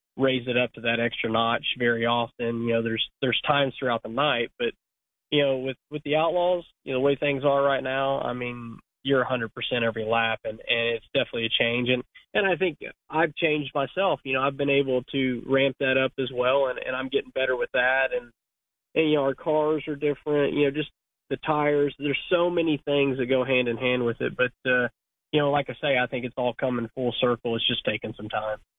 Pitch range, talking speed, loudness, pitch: 120-145 Hz, 235 wpm, -25 LUFS, 130 Hz